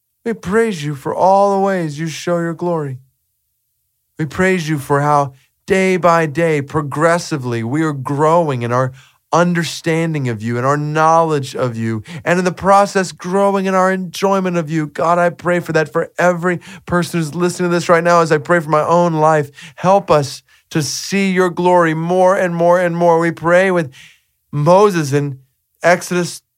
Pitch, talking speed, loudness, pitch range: 165 Hz, 185 wpm, -15 LUFS, 150-180 Hz